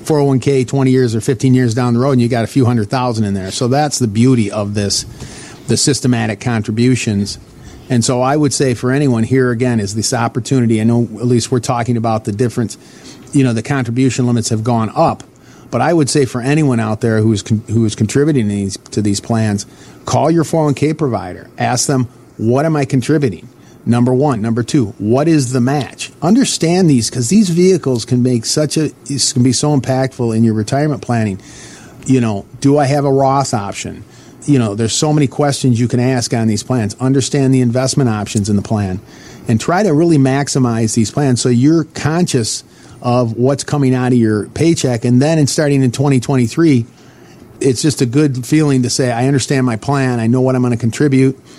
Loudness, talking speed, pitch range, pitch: -14 LUFS, 205 wpm, 115-140 Hz, 125 Hz